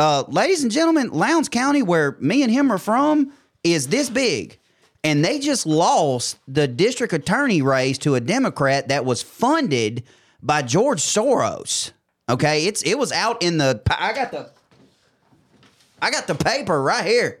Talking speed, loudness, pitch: 165 wpm, -20 LUFS, 165 Hz